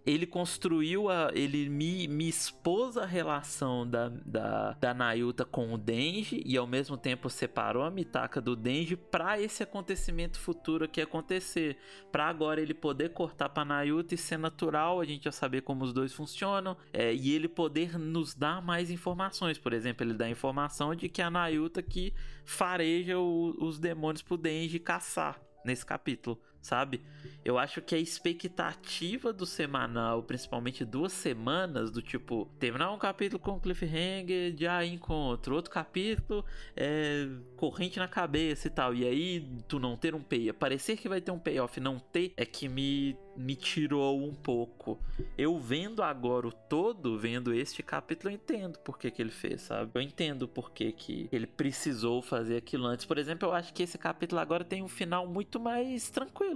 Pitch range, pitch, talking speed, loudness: 130-175 Hz, 155 Hz, 180 wpm, -34 LUFS